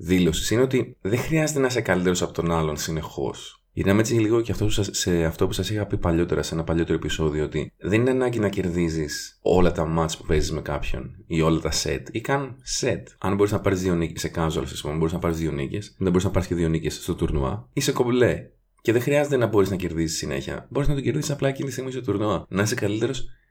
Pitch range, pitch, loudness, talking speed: 80-110 Hz, 90 Hz, -24 LUFS, 245 wpm